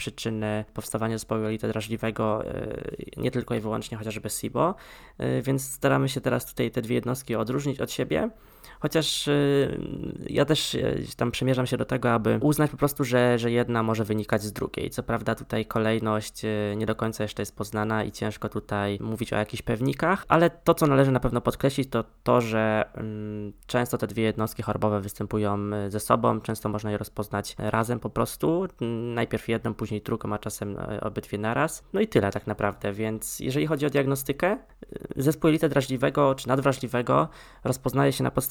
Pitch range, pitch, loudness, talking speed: 105-135 Hz, 115 Hz, -27 LUFS, 170 wpm